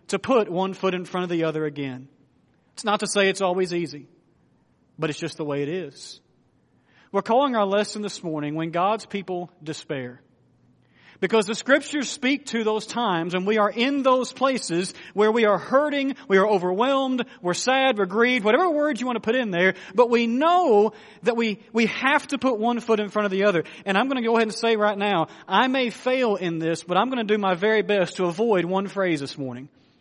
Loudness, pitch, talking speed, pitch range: -23 LUFS, 205 Hz, 220 wpm, 175-235 Hz